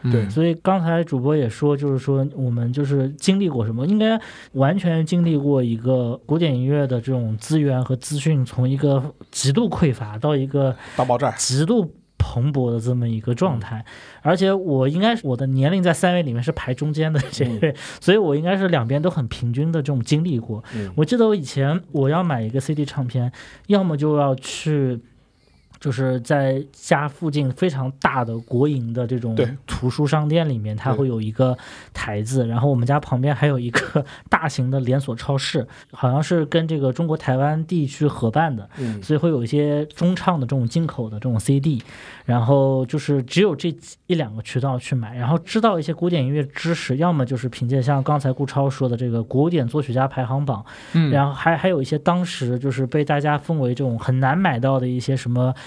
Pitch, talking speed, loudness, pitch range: 140 Hz, 305 characters per minute, -21 LUFS, 125-155 Hz